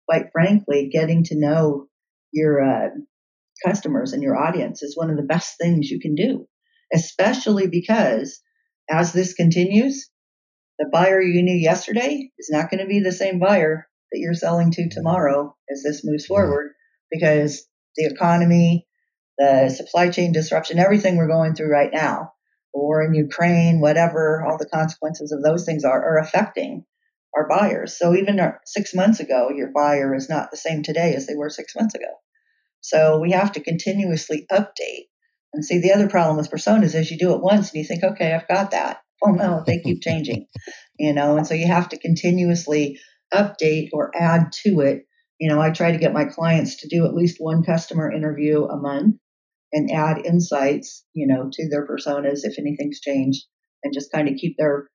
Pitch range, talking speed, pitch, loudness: 150-190 Hz, 190 wpm, 165 Hz, -20 LUFS